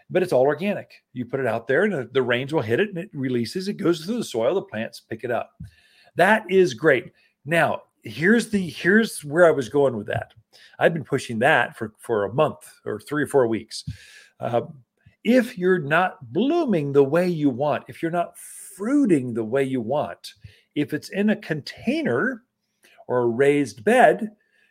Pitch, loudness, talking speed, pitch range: 160 Hz, -22 LUFS, 195 wpm, 130-195 Hz